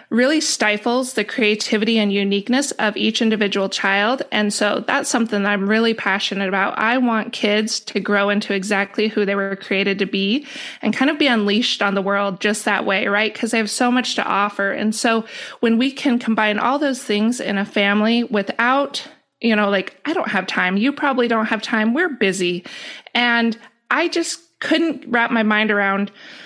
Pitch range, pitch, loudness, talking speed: 205-250 Hz, 220 Hz, -18 LUFS, 195 wpm